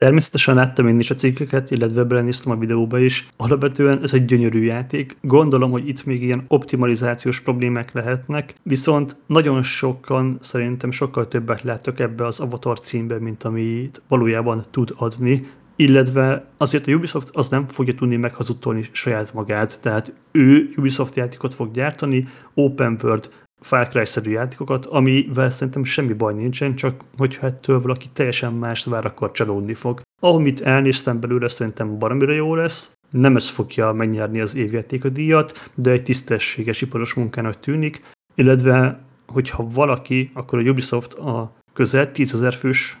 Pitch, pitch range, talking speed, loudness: 130 Hz, 120-135 Hz, 150 wpm, -19 LUFS